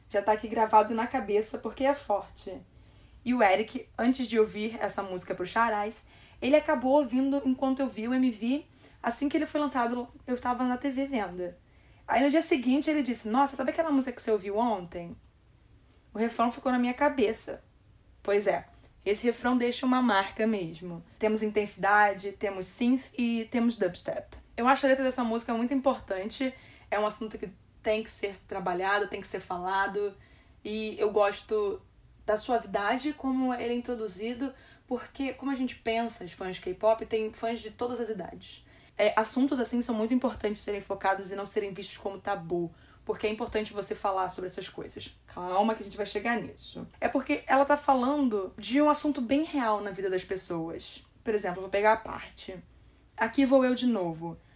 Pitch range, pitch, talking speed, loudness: 200-255 Hz, 225 Hz, 185 wpm, -29 LUFS